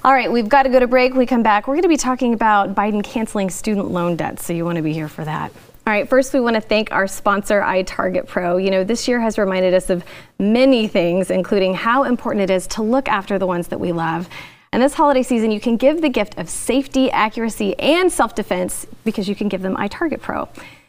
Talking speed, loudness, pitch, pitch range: 250 wpm, -18 LUFS, 215 Hz, 185-255 Hz